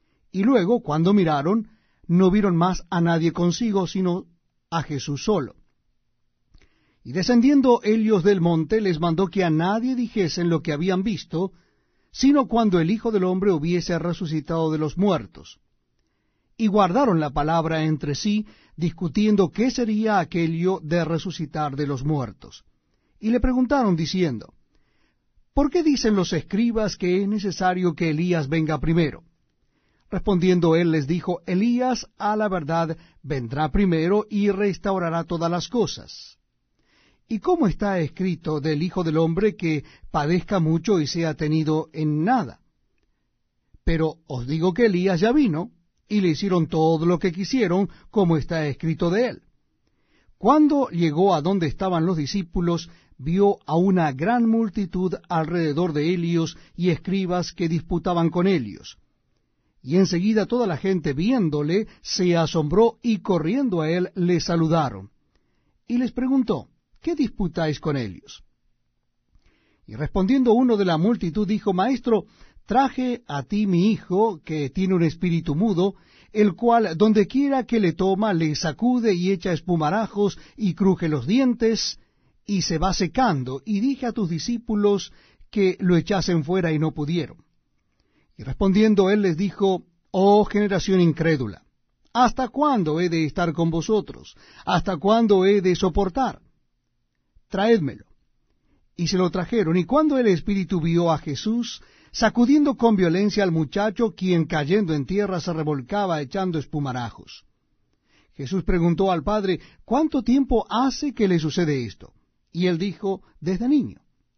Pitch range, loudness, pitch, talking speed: 165-210 Hz, -22 LUFS, 185 Hz, 145 wpm